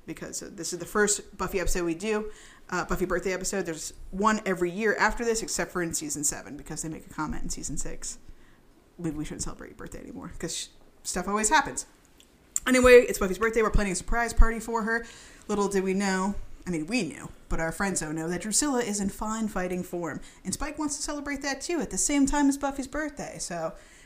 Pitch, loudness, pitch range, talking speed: 200 Hz, -28 LUFS, 175-230 Hz, 220 wpm